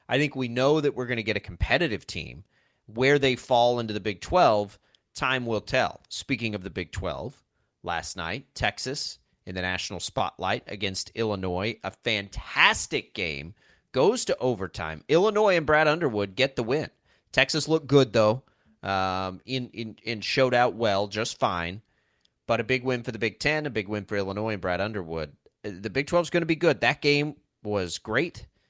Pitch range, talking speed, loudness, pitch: 100-130 Hz, 185 wpm, -26 LUFS, 115 Hz